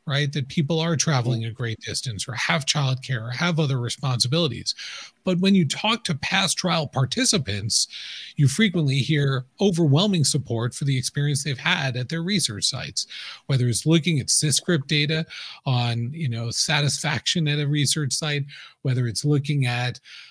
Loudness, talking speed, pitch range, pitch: -23 LUFS, 165 wpm, 130-165 Hz, 145 Hz